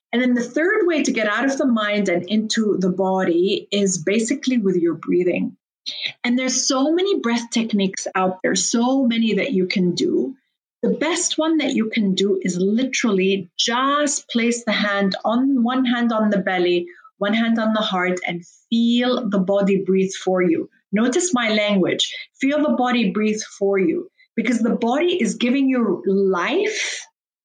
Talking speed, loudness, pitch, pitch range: 175 wpm, -20 LUFS, 225 Hz, 195-255 Hz